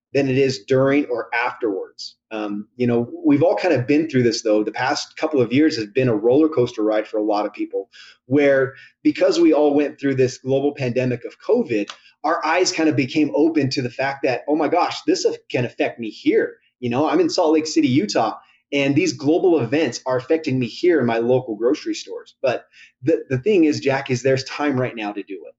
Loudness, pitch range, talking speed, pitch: -20 LUFS, 125-165 Hz, 225 wpm, 140 Hz